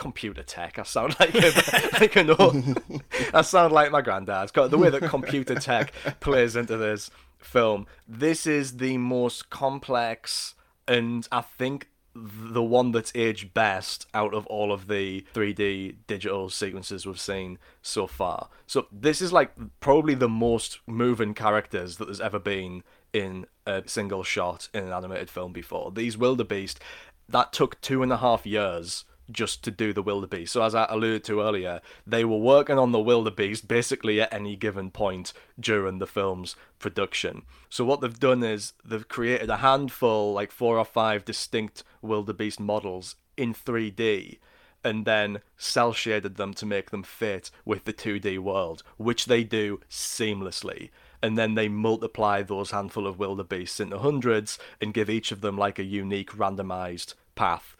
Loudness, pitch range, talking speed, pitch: -26 LUFS, 100-120 Hz, 165 wpm, 110 Hz